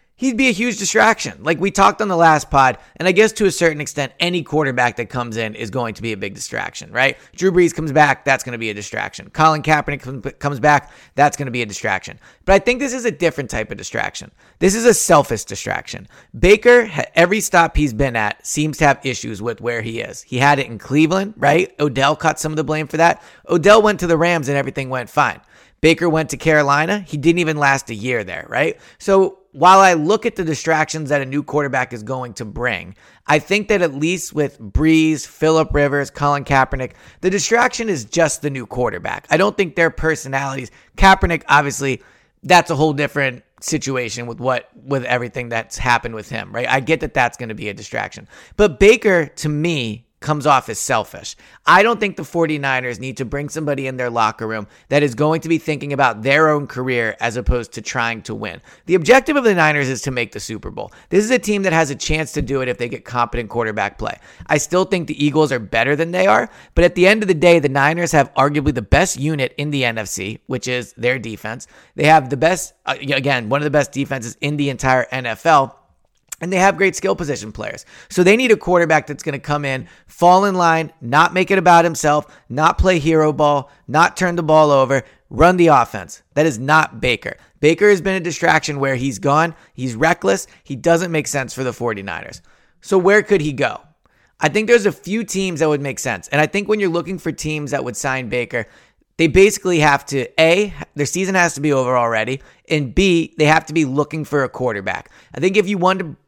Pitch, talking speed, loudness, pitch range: 150 Hz, 225 wpm, -17 LUFS, 130-170 Hz